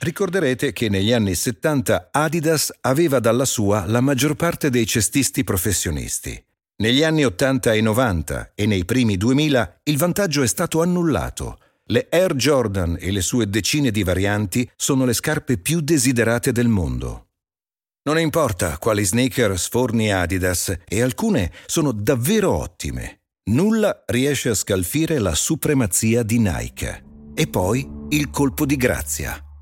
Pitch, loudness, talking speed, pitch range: 125 Hz, -20 LUFS, 140 wpm, 100-150 Hz